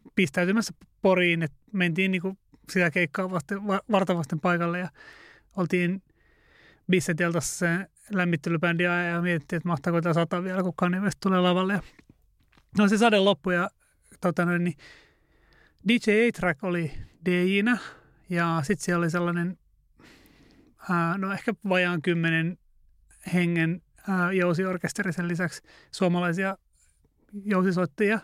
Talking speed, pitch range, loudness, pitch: 115 wpm, 175-195 Hz, -26 LUFS, 180 Hz